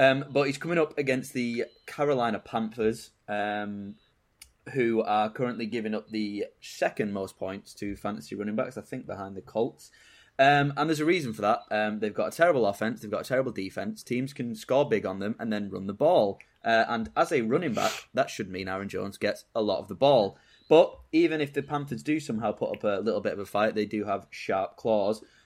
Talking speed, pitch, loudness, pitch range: 220 wpm, 115 Hz, -28 LUFS, 105-140 Hz